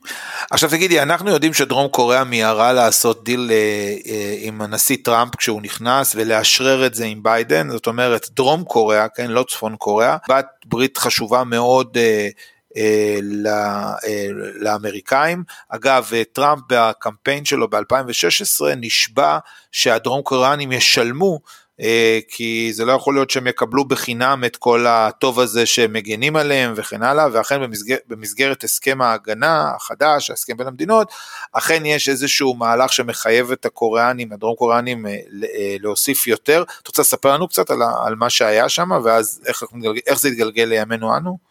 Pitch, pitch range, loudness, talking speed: 120 Hz, 110-135 Hz, -17 LUFS, 135 wpm